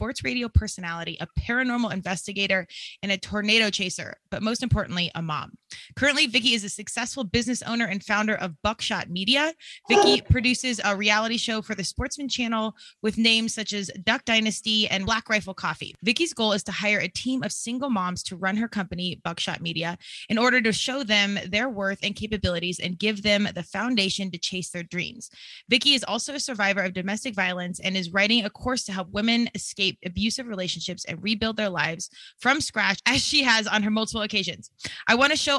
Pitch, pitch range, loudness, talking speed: 210 Hz, 190-230 Hz, -24 LUFS, 195 wpm